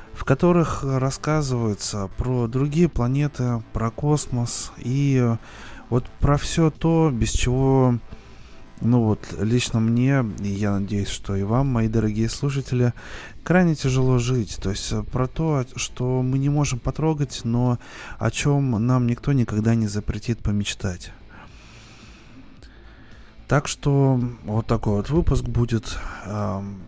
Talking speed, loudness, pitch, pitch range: 125 wpm, -23 LUFS, 120 Hz, 110-135 Hz